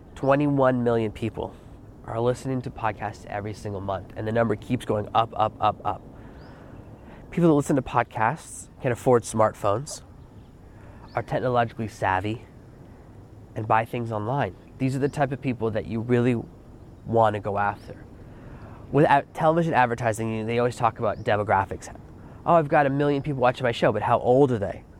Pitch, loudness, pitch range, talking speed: 115 Hz, -24 LUFS, 105-125 Hz, 165 wpm